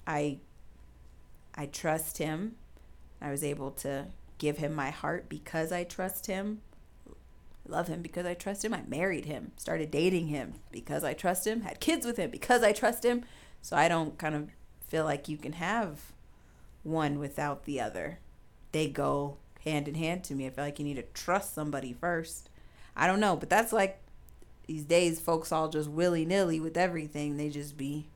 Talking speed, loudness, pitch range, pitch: 185 wpm, -32 LUFS, 145-180 Hz, 155 Hz